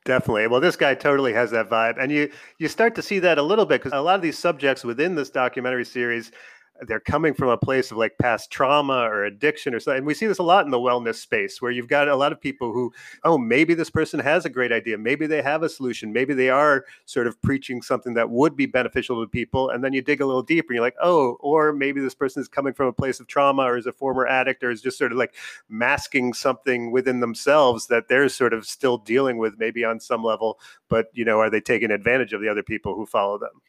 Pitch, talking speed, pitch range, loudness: 130 Hz, 260 wpm, 120-145 Hz, -22 LUFS